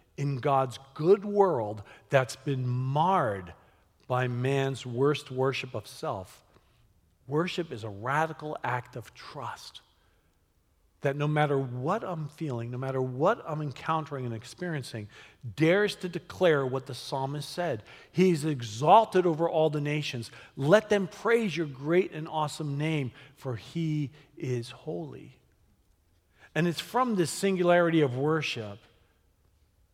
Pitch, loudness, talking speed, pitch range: 135 Hz, -29 LUFS, 130 wpm, 115-160 Hz